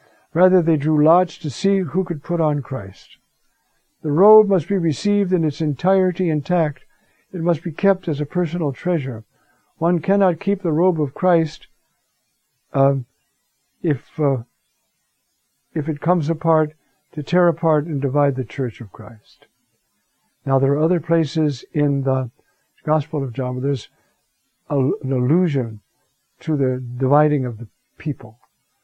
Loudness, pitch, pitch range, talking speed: -19 LUFS, 155 Hz, 135-175 Hz, 150 wpm